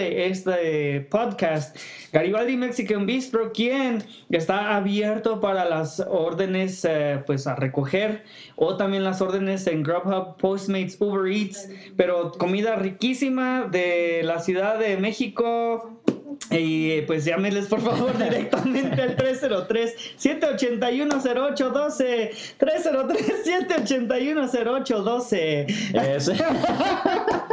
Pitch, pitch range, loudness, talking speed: 215 Hz, 185-250 Hz, -24 LUFS, 100 wpm